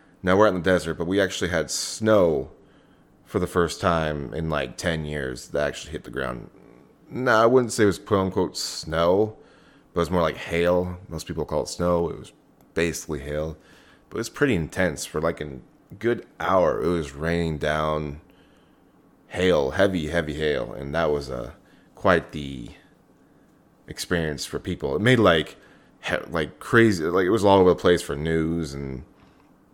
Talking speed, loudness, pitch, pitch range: 185 wpm, -24 LUFS, 85 Hz, 75-95 Hz